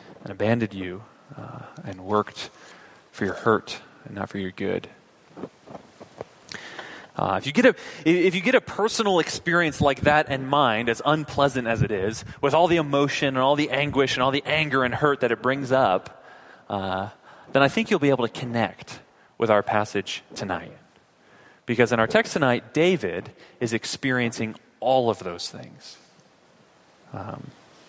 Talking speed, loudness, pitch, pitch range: 170 wpm, -23 LUFS, 130 Hz, 110-150 Hz